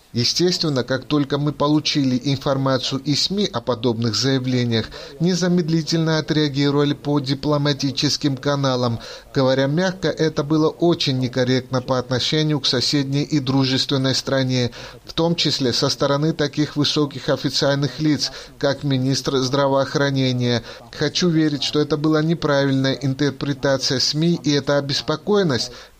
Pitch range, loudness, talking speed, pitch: 130-150 Hz, -20 LUFS, 120 wpm, 140 Hz